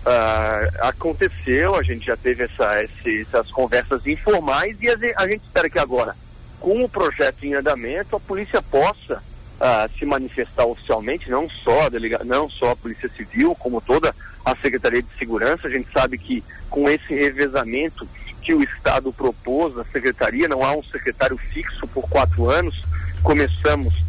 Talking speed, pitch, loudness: 165 wpm, 135 Hz, -21 LUFS